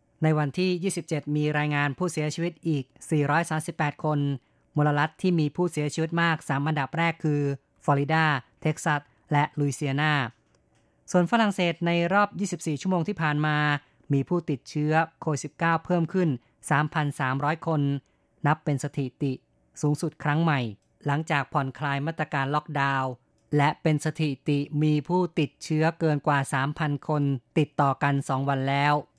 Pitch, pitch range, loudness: 150 Hz, 145-160 Hz, -26 LUFS